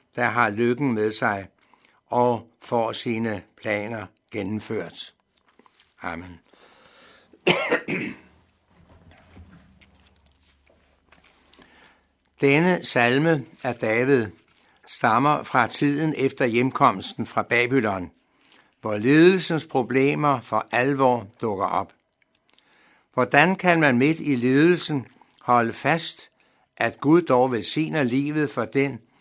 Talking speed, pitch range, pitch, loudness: 90 wpm, 105-140 Hz, 120 Hz, -22 LUFS